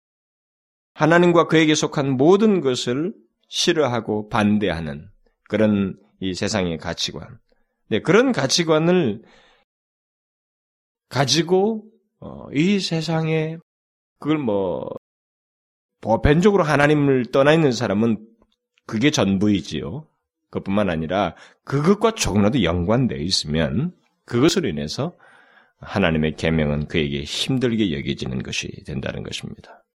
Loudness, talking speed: -20 LUFS, 250 characters per minute